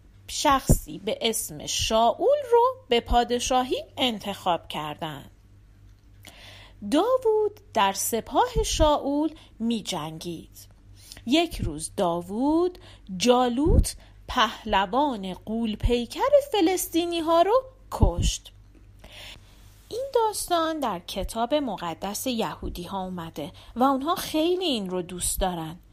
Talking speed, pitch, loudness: 95 wpm, 225 Hz, -25 LUFS